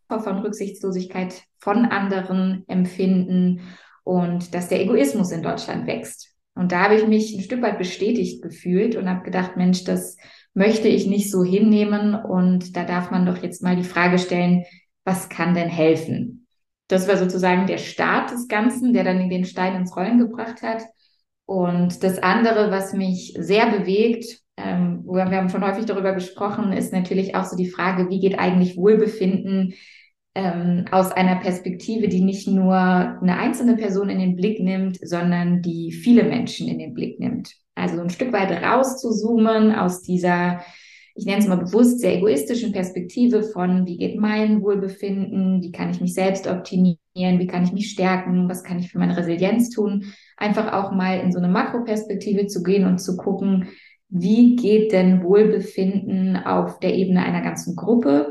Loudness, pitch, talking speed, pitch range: -20 LUFS, 190 Hz, 170 wpm, 180-210 Hz